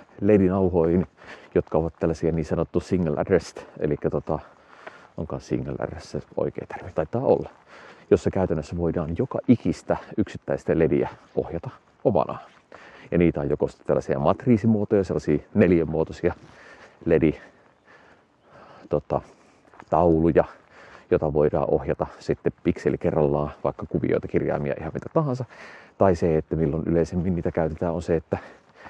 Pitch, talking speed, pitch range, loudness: 85 Hz, 120 wpm, 80-90 Hz, -24 LUFS